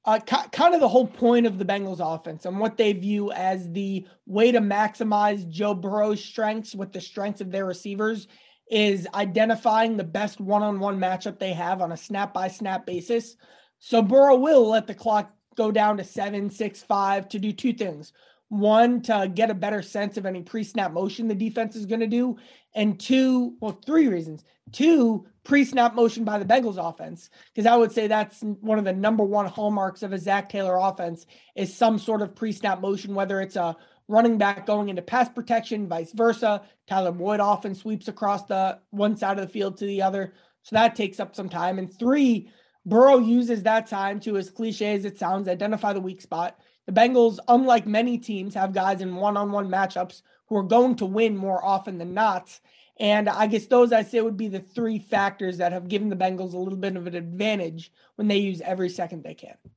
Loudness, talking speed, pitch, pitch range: -24 LUFS, 205 wpm, 210 Hz, 190-225 Hz